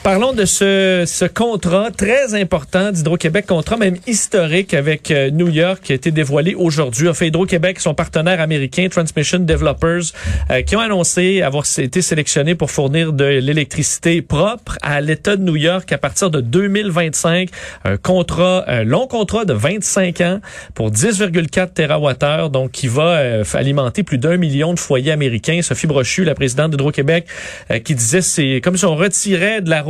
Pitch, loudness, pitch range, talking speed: 170 Hz, -15 LUFS, 150-185 Hz, 170 wpm